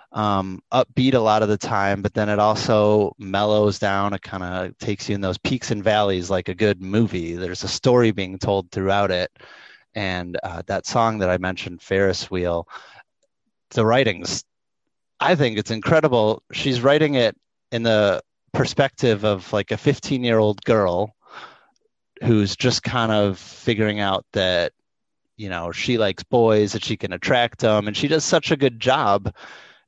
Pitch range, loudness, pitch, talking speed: 100-120 Hz, -21 LUFS, 105 Hz, 175 wpm